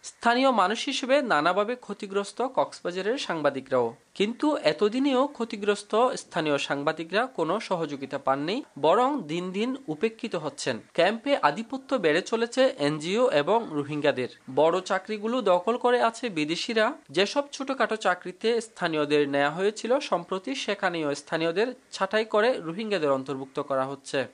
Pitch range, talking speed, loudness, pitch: 155-240 Hz, 120 wpm, -26 LUFS, 205 Hz